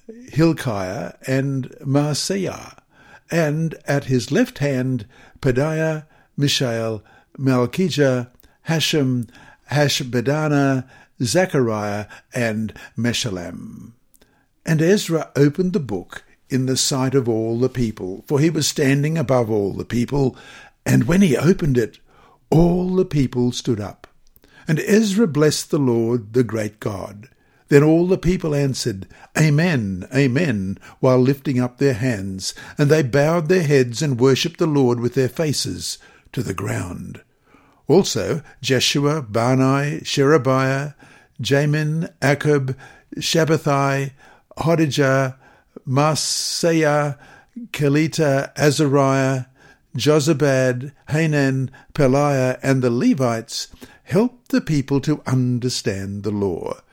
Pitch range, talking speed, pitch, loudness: 125-155 Hz, 110 wpm, 135 Hz, -19 LUFS